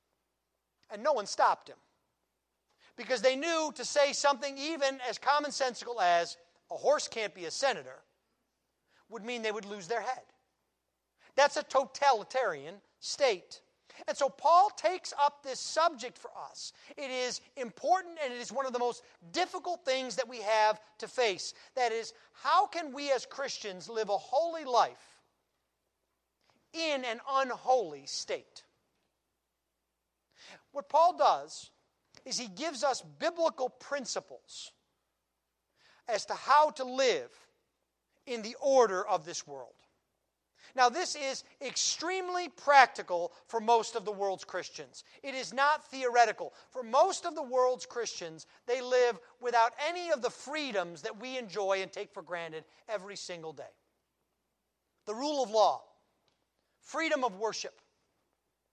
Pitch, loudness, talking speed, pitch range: 255 Hz, -31 LUFS, 140 wpm, 210-285 Hz